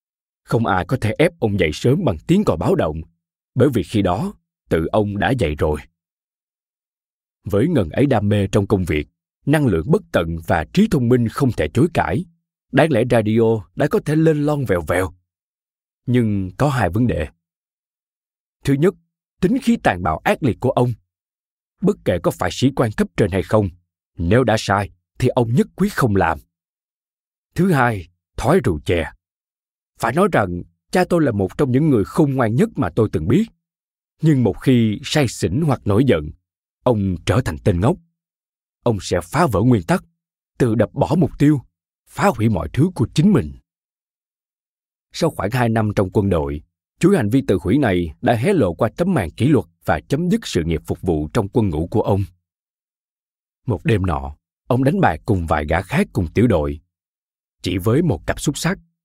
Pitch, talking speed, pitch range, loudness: 115 Hz, 195 wpm, 90-150 Hz, -19 LUFS